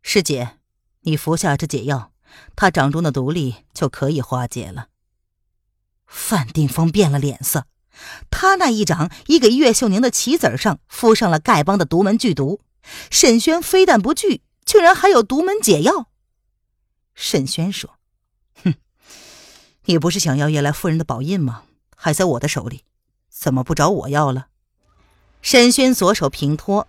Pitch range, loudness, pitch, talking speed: 135-215 Hz, -17 LUFS, 155 Hz, 225 characters per minute